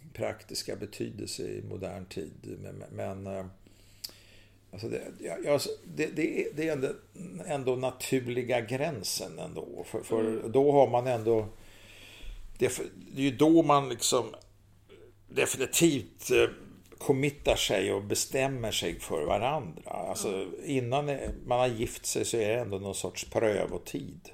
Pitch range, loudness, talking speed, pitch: 100-135 Hz, -30 LUFS, 130 wpm, 115 Hz